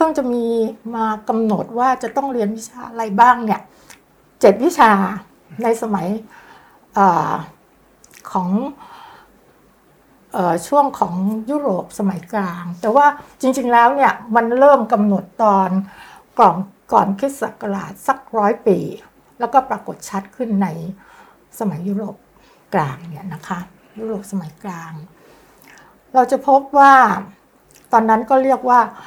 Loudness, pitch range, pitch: -17 LUFS, 195-255 Hz, 225 Hz